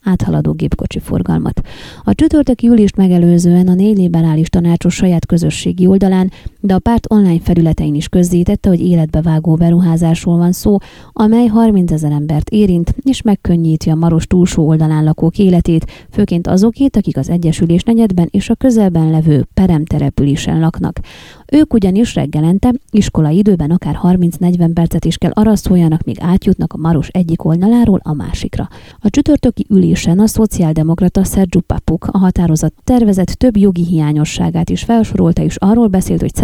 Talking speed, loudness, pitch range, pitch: 150 wpm, -12 LUFS, 165-205 Hz, 175 Hz